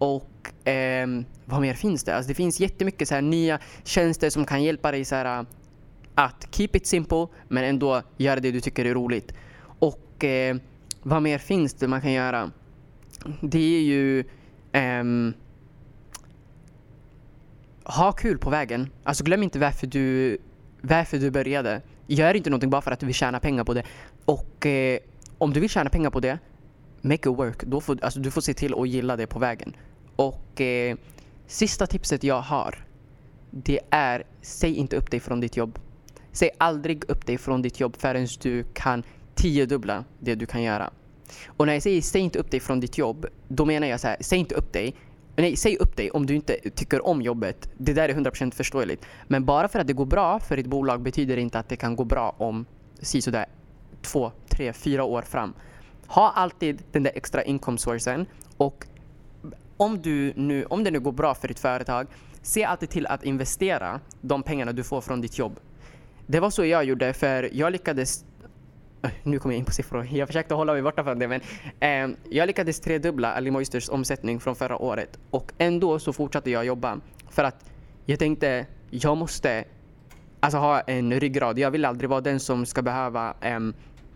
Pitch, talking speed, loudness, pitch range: 135 Hz, 190 wpm, -25 LUFS, 125-150 Hz